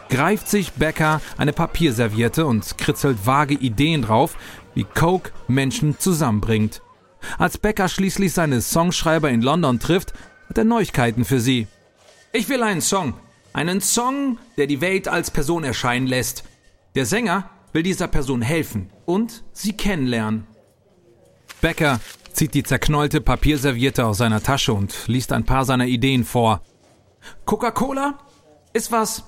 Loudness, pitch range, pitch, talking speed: -20 LUFS, 120-180 Hz, 145 Hz, 135 wpm